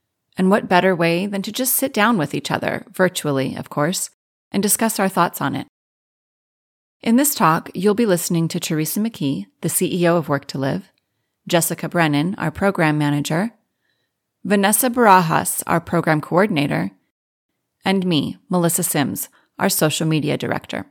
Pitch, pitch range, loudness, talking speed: 175 Hz, 155-200 Hz, -19 LUFS, 155 wpm